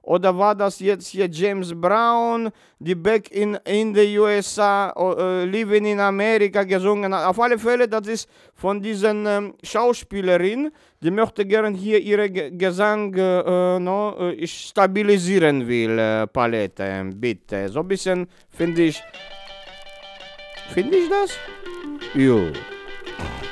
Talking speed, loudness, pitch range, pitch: 130 wpm, -20 LUFS, 180-210 Hz, 195 Hz